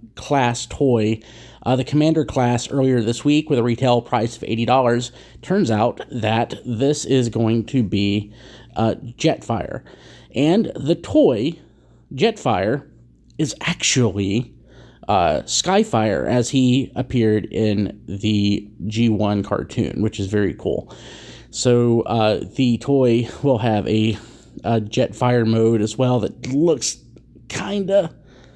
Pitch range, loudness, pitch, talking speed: 110-130 Hz, -19 LUFS, 115 Hz, 125 wpm